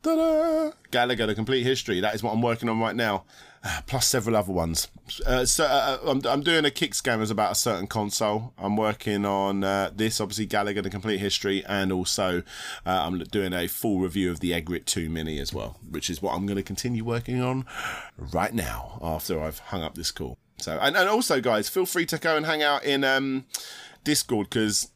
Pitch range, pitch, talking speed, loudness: 95-125 Hz, 105 Hz, 210 wpm, -26 LUFS